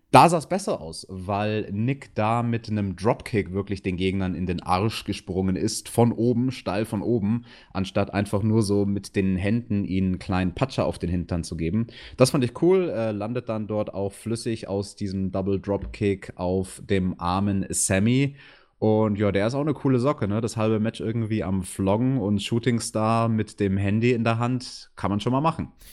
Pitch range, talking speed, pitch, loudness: 95-115 Hz, 195 wpm, 105 Hz, -25 LUFS